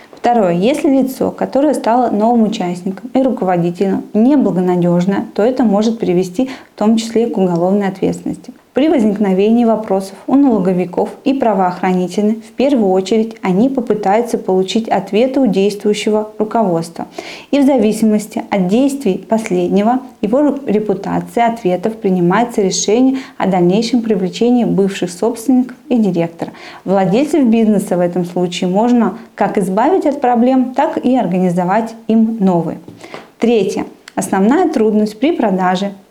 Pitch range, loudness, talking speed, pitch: 190-245 Hz, -14 LUFS, 125 wpm, 215 Hz